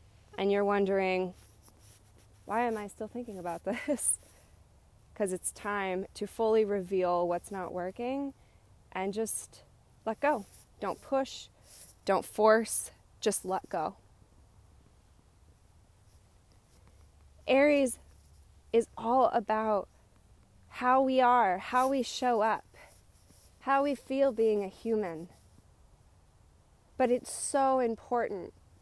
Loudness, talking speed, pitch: -31 LUFS, 105 wpm, 195 Hz